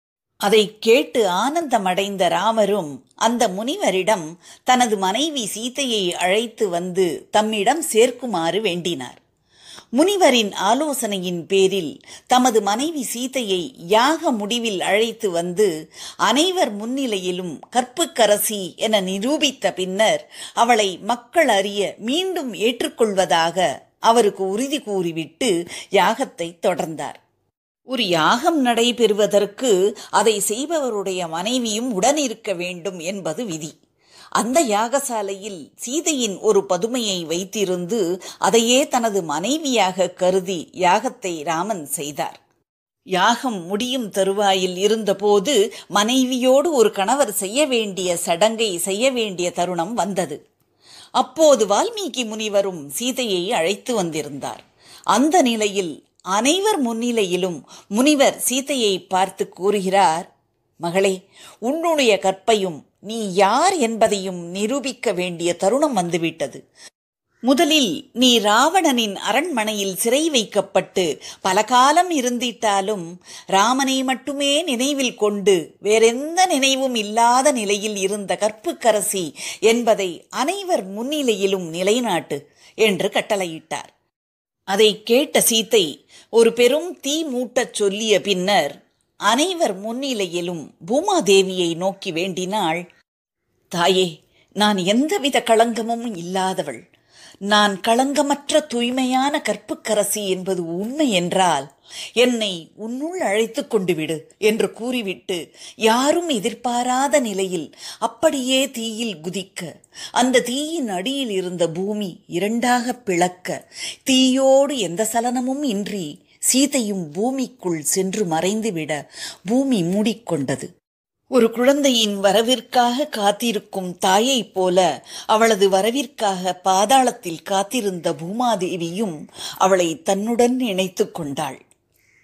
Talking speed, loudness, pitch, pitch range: 90 wpm, -19 LUFS, 215 Hz, 190-255 Hz